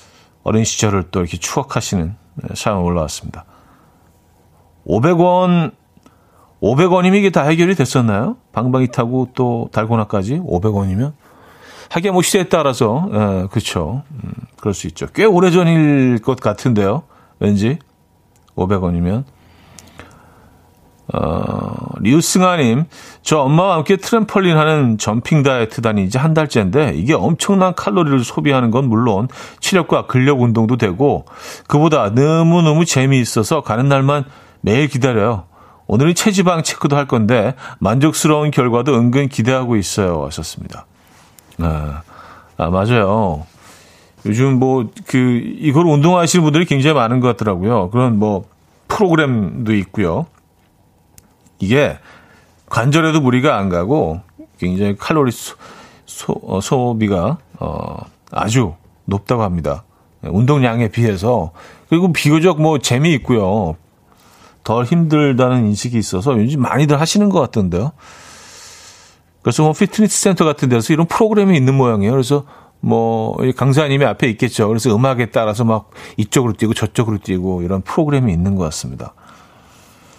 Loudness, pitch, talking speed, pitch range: -15 LUFS, 120 Hz, 295 characters per minute, 100-150 Hz